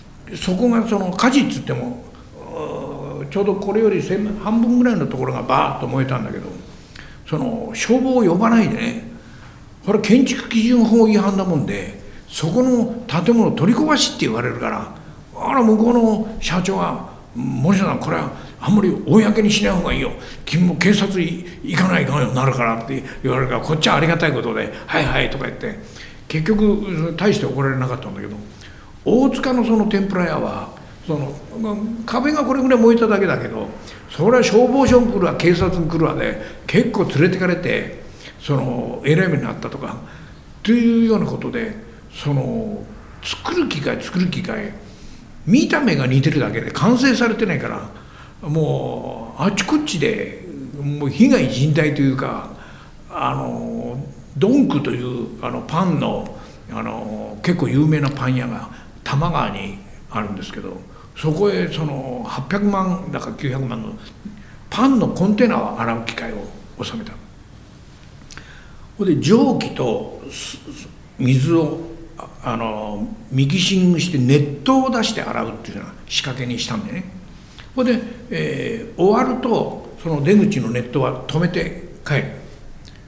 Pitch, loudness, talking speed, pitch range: 185 Hz, -18 LUFS, 300 characters per minute, 140-230 Hz